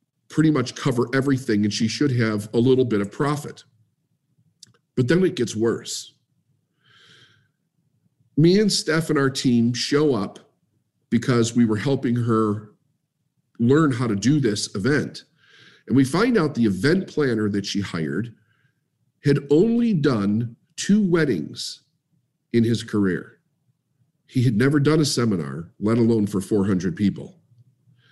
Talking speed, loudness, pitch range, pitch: 140 wpm, -21 LUFS, 115-150 Hz, 130 Hz